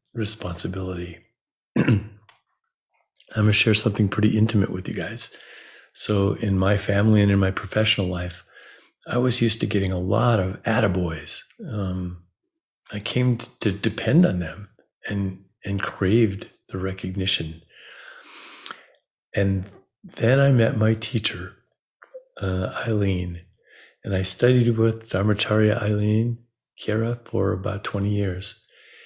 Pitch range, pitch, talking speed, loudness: 95-115 Hz, 105 Hz, 125 wpm, -23 LUFS